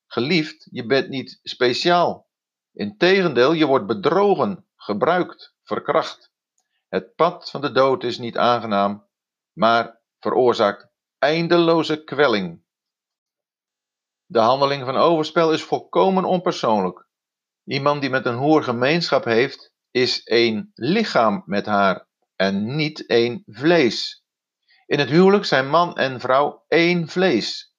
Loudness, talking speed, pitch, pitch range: -19 LUFS, 120 wpm, 145 Hz, 120-170 Hz